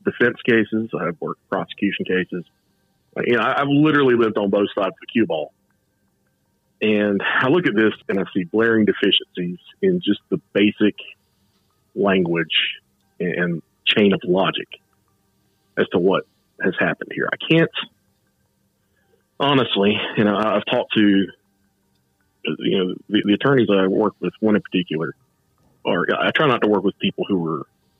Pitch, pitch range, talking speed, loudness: 100 Hz, 90-110 Hz, 160 wpm, -20 LUFS